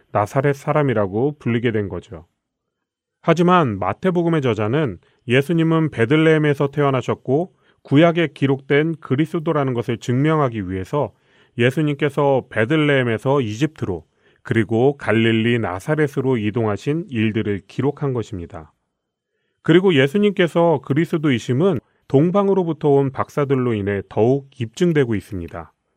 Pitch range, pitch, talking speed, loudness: 115-155 Hz, 135 Hz, 320 characters per minute, -19 LUFS